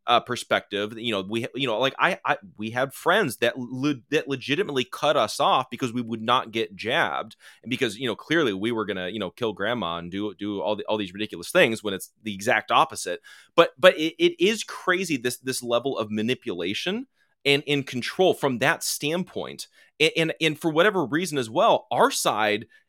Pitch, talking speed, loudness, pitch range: 130 Hz, 205 wpm, -24 LUFS, 110-160 Hz